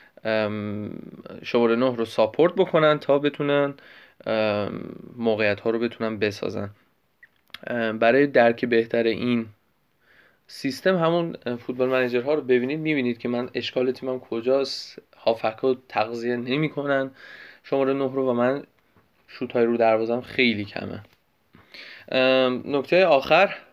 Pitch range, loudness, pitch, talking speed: 115-135 Hz, -23 LUFS, 125 Hz, 125 wpm